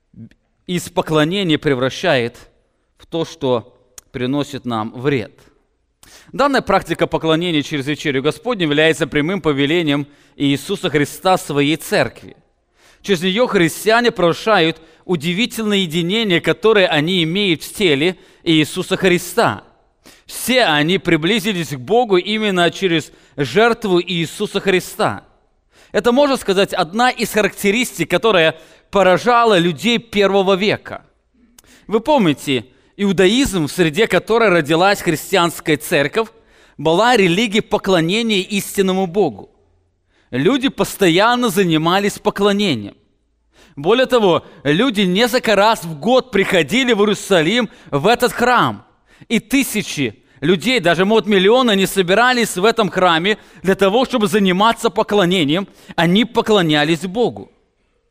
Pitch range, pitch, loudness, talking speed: 160-220 Hz, 190 Hz, -16 LUFS, 110 wpm